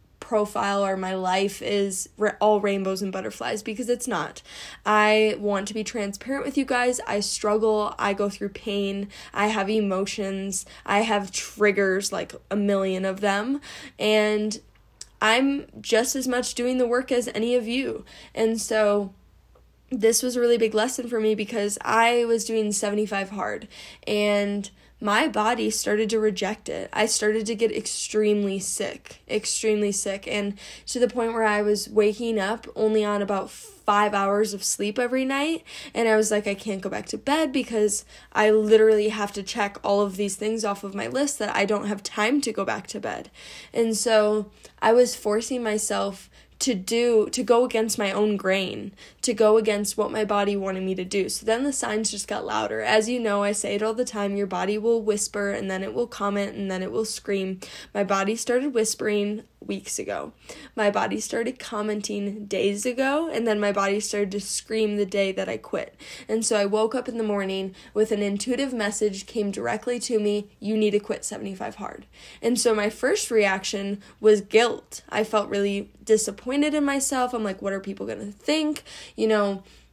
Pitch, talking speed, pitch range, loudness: 210 Hz, 190 wpm, 200-230 Hz, -24 LUFS